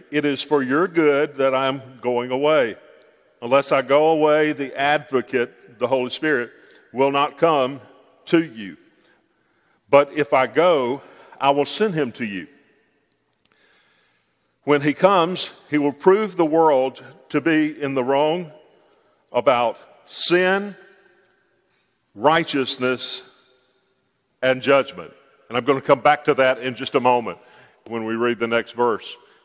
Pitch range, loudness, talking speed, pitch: 130-150 Hz, -20 LUFS, 145 wpm, 140 Hz